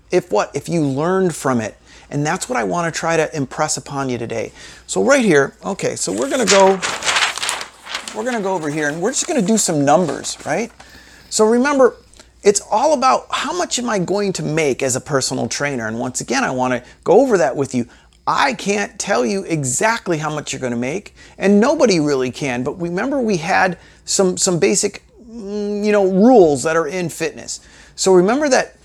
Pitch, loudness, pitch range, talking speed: 180 Hz, -17 LUFS, 140-205 Hz, 210 wpm